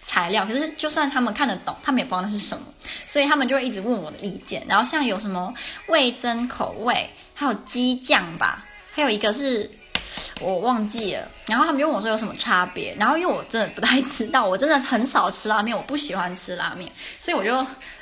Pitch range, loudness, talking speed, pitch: 210-285 Hz, -23 LUFS, 335 characters per minute, 250 Hz